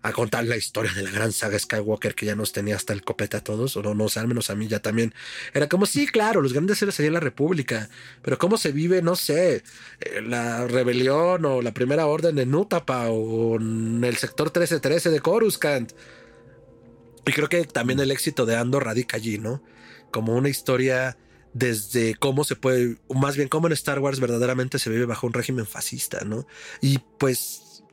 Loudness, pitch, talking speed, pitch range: -24 LUFS, 125 Hz, 205 wpm, 115-145 Hz